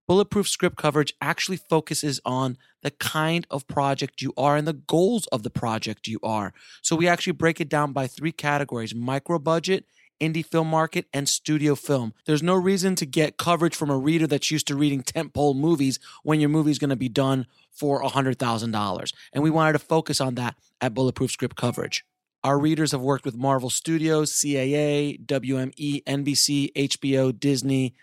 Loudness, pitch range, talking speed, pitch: -24 LUFS, 135-160 Hz, 185 wpm, 145 Hz